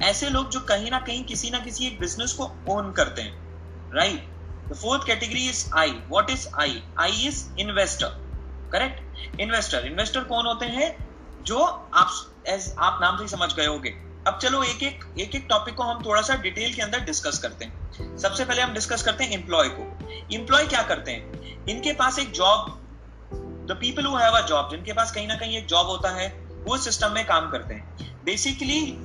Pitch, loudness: 210 Hz, -24 LUFS